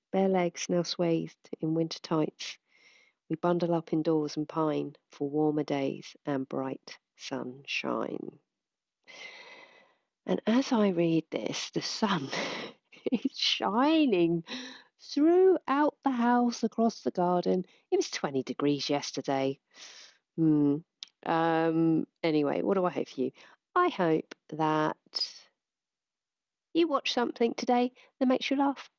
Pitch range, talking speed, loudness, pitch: 155-250 Hz, 120 wpm, -29 LUFS, 175 Hz